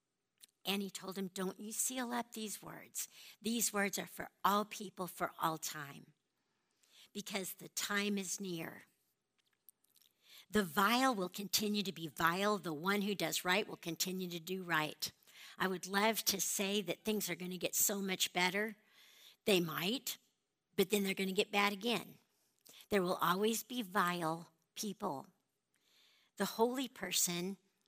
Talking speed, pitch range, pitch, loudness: 160 wpm, 180-210 Hz, 195 Hz, -37 LUFS